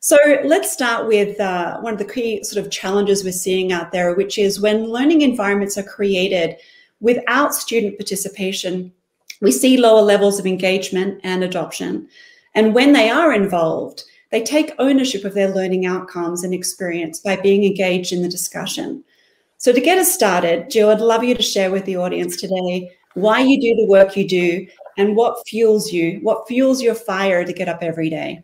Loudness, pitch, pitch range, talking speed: -17 LUFS, 200 Hz, 185-235 Hz, 190 wpm